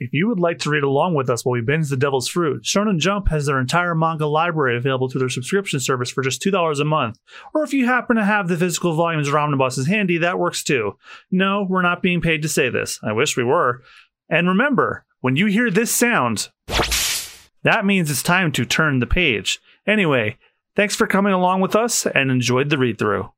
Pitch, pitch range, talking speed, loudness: 165 Hz, 135-195 Hz, 220 wpm, -19 LUFS